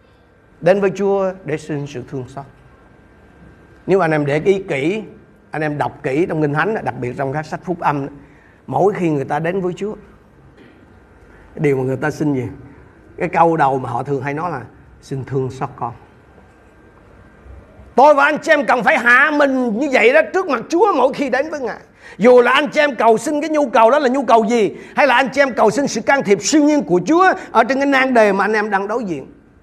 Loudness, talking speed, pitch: -16 LUFS, 230 wpm, 185 Hz